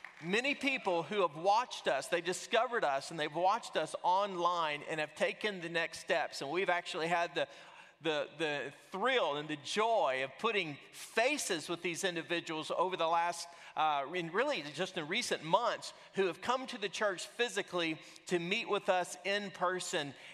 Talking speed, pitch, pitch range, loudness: 175 wpm, 180 Hz, 165-200 Hz, -35 LUFS